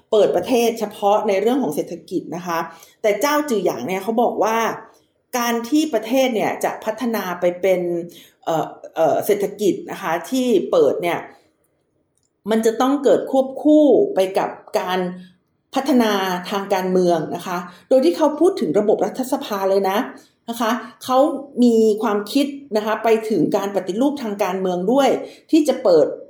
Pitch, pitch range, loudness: 220 Hz, 190-265 Hz, -19 LUFS